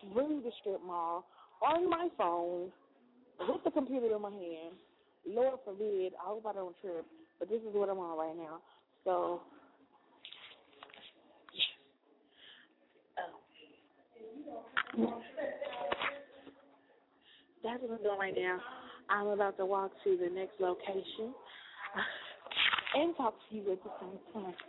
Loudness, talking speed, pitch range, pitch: -37 LUFS, 135 wpm, 185-255 Hz, 200 Hz